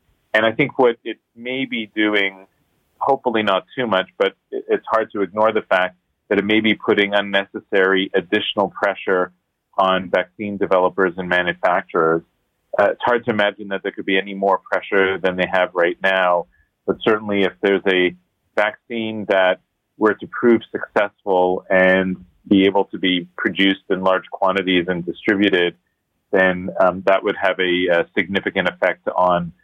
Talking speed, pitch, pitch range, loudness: 165 wpm, 95 Hz, 90-105 Hz, -19 LUFS